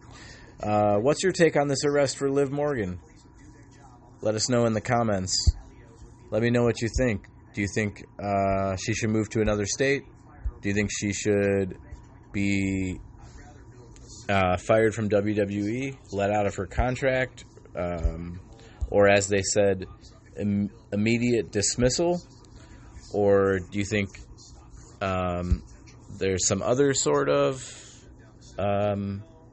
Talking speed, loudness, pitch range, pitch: 135 wpm, -26 LUFS, 100-120 Hz, 105 Hz